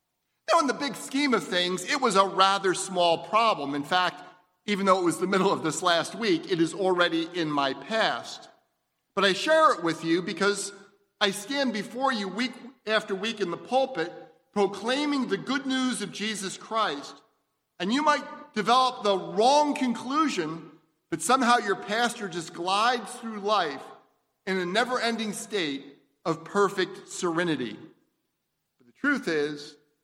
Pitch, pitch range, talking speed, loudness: 200 Hz, 175-250 Hz, 165 wpm, -26 LUFS